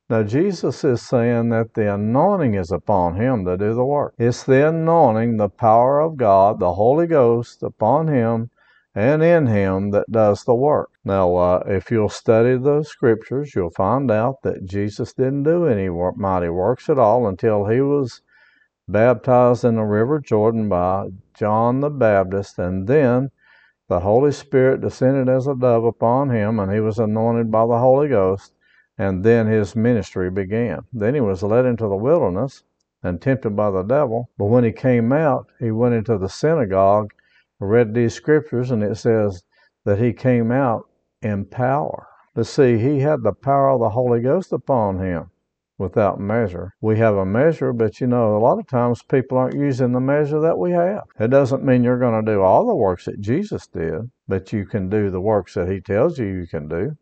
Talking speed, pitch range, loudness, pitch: 190 wpm, 100-130 Hz, -19 LUFS, 115 Hz